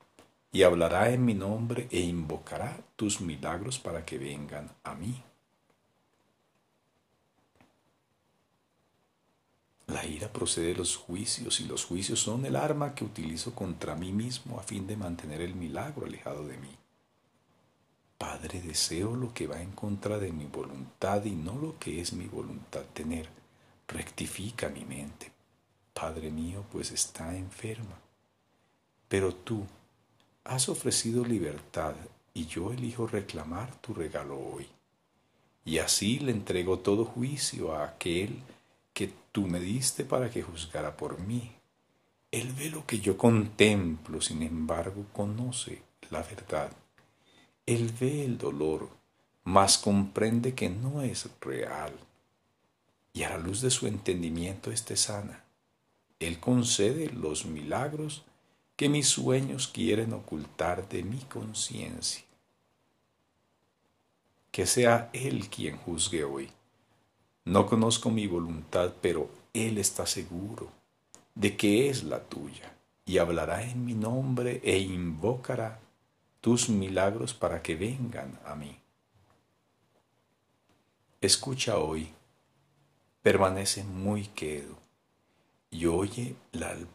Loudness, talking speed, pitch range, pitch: -31 LUFS, 125 wpm, 85-120 Hz, 105 Hz